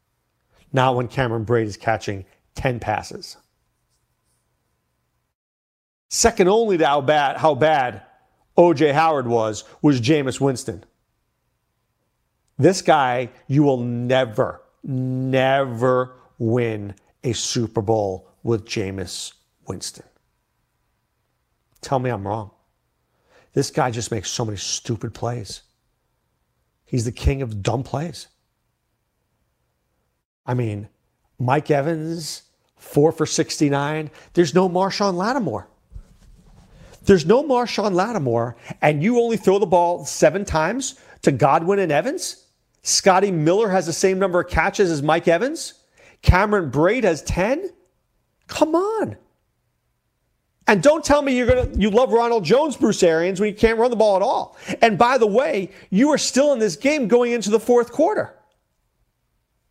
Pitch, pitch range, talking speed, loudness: 155 Hz, 120-205 Hz, 130 wpm, -20 LUFS